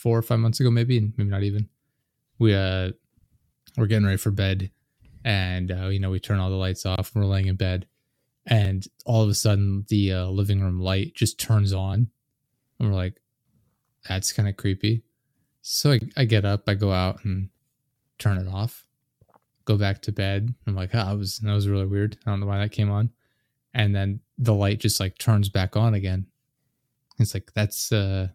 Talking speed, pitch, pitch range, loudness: 205 wpm, 105 Hz, 95-115 Hz, -24 LUFS